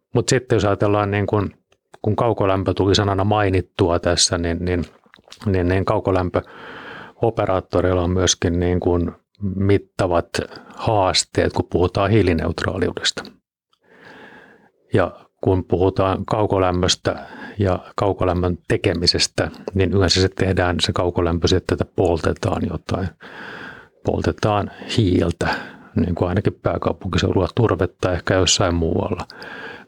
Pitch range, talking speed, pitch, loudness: 90-100 Hz, 100 wpm, 95 Hz, -20 LUFS